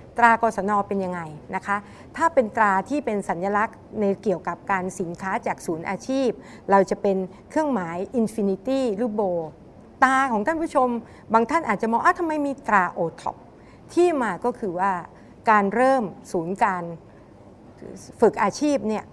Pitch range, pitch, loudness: 190-245 Hz, 210 Hz, -23 LUFS